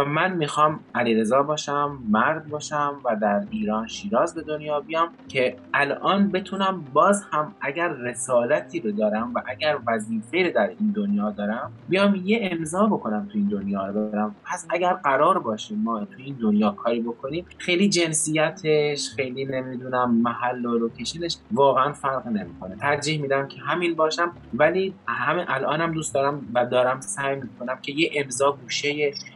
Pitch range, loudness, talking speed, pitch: 120-165 Hz, -24 LUFS, 155 wpm, 140 Hz